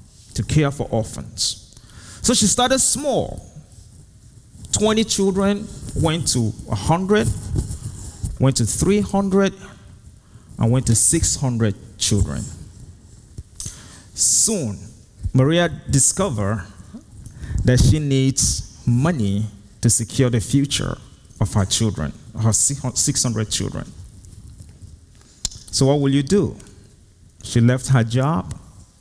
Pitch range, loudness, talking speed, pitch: 100-135 Hz, -19 LUFS, 95 wpm, 110 Hz